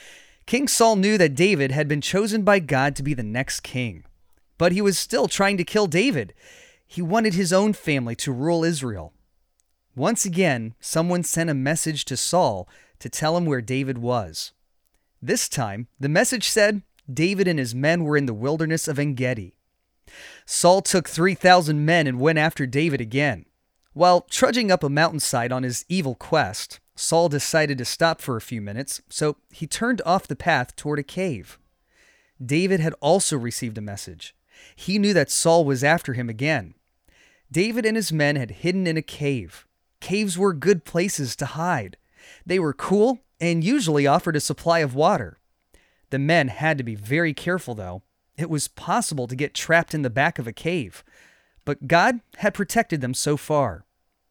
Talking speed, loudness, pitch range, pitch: 180 wpm, -22 LUFS, 130-180 Hz, 155 Hz